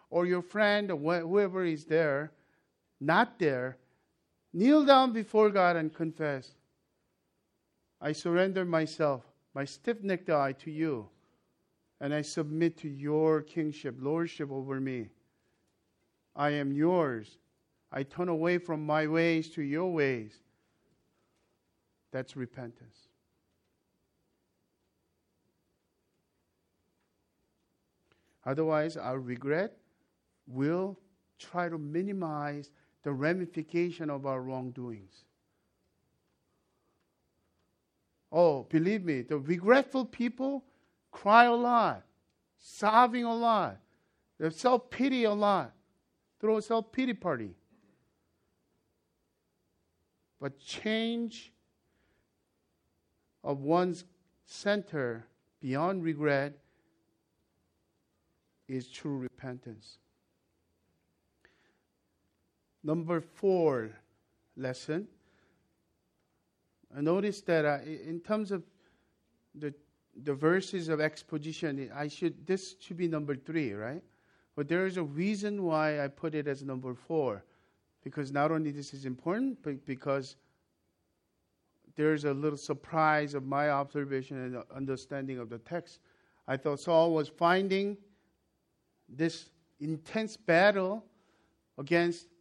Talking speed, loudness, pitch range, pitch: 100 wpm, -31 LUFS, 135-175 Hz, 155 Hz